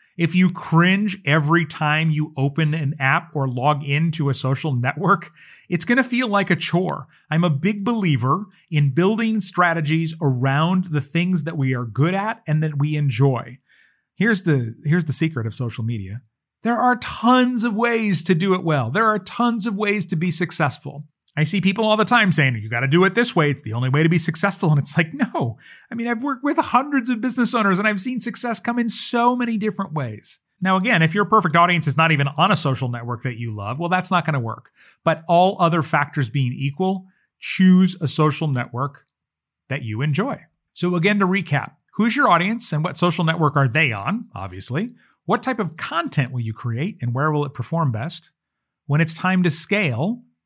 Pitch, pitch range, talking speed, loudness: 165 Hz, 145-200 Hz, 210 wpm, -20 LUFS